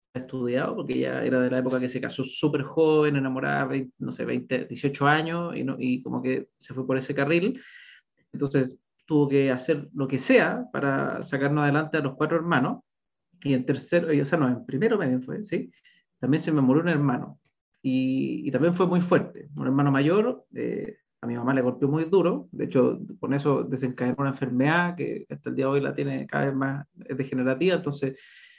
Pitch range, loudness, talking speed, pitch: 130-160 Hz, -26 LUFS, 205 wpm, 140 Hz